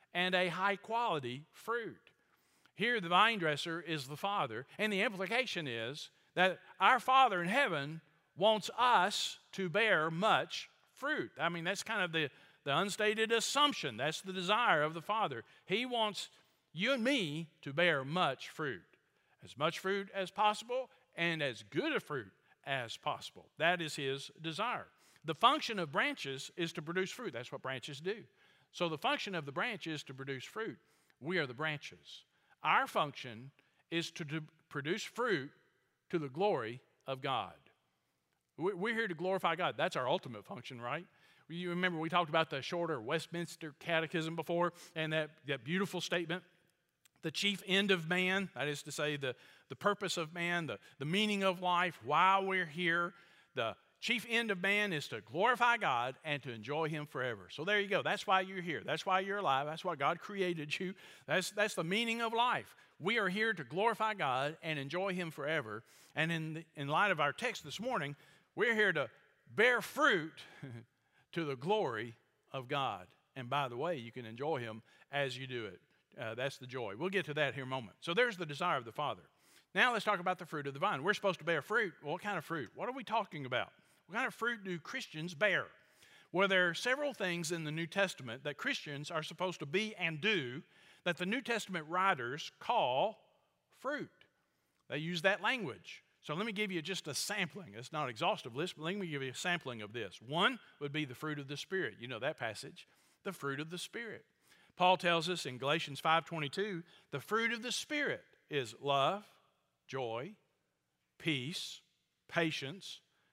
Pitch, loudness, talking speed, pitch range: 170 Hz, -36 LUFS, 190 wpm, 150-195 Hz